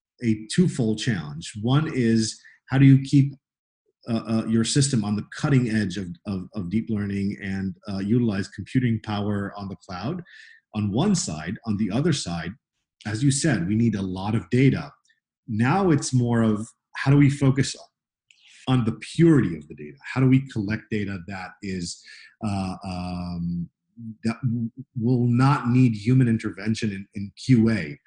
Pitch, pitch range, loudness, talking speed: 115 Hz, 100-130 Hz, -24 LUFS, 170 wpm